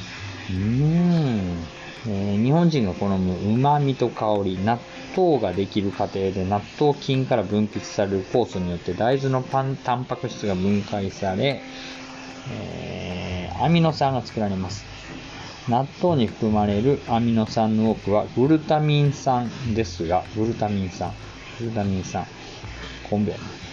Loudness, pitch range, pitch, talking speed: -23 LUFS, 100-130 Hz, 110 Hz, 270 characters per minute